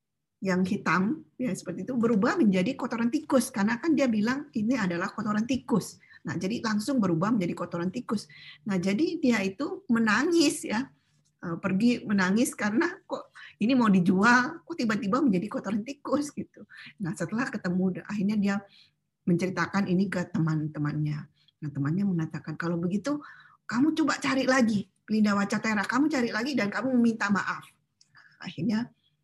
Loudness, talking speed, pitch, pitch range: -27 LUFS, 145 wpm, 210 Hz, 180-255 Hz